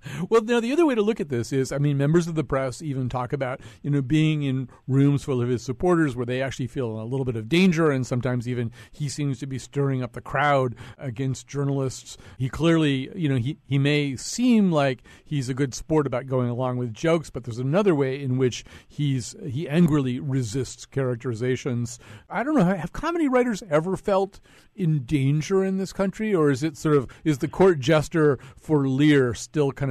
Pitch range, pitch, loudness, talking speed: 130-160 Hz, 140 Hz, -24 LUFS, 210 wpm